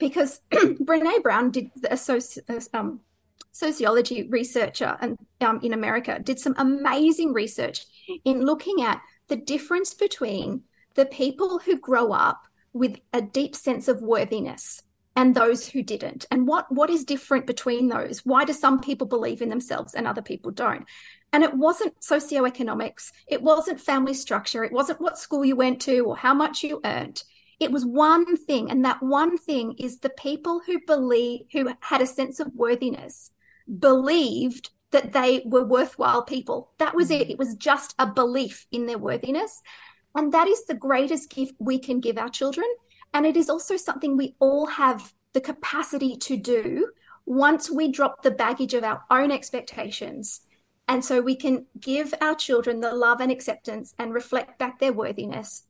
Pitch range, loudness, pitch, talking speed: 250-305 Hz, -24 LUFS, 270 Hz, 175 wpm